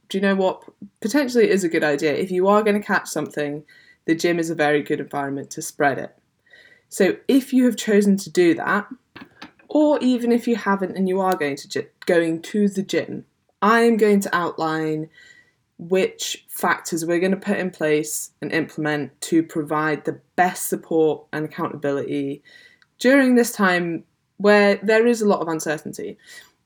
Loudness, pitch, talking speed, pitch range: -21 LUFS, 185 Hz, 180 wpm, 155-220 Hz